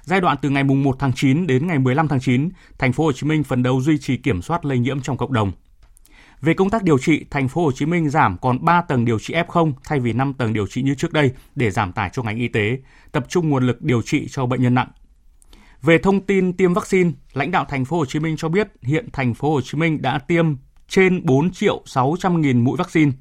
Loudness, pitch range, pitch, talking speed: -19 LUFS, 125-165 Hz, 140 Hz, 255 wpm